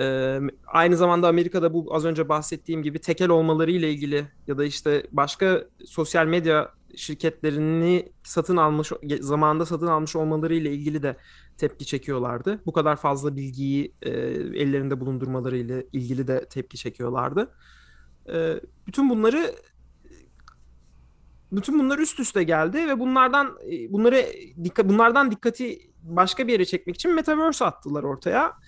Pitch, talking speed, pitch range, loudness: 160 Hz, 135 wpm, 140-180 Hz, -23 LUFS